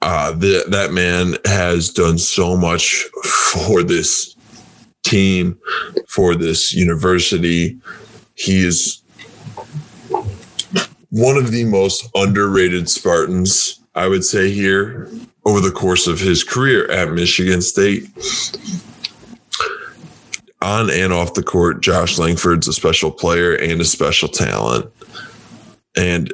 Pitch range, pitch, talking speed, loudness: 85-100 Hz, 90 Hz, 115 wpm, -15 LUFS